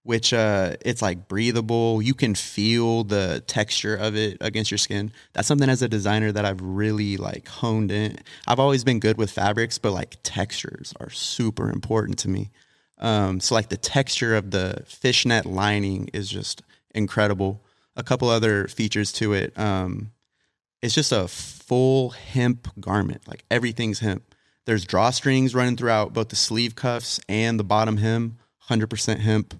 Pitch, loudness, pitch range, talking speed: 110 Hz, -23 LUFS, 105-120 Hz, 165 wpm